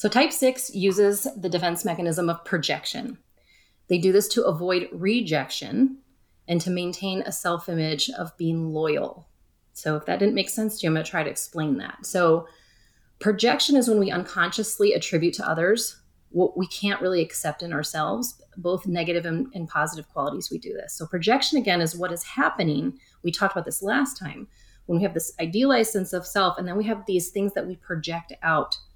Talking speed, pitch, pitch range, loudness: 195 wpm, 180 Hz, 165-210 Hz, -25 LUFS